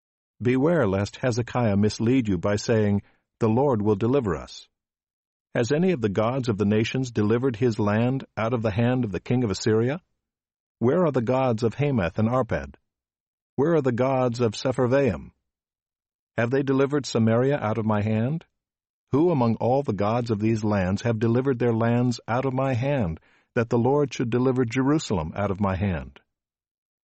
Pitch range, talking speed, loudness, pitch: 105-130 Hz, 180 wpm, -24 LUFS, 120 Hz